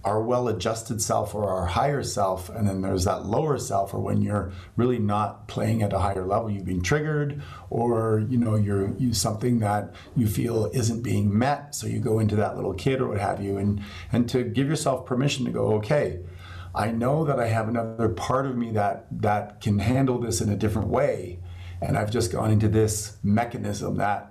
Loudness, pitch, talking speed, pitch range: -25 LUFS, 110 Hz, 205 wpm, 100-120 Hz